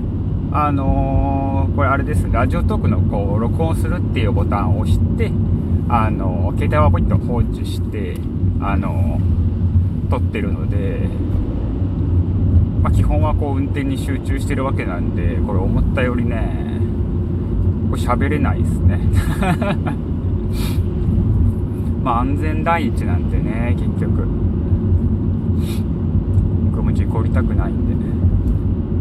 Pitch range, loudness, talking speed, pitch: 90-100 Hz, -18 LUFS, 240 characters per minute, 95 Hz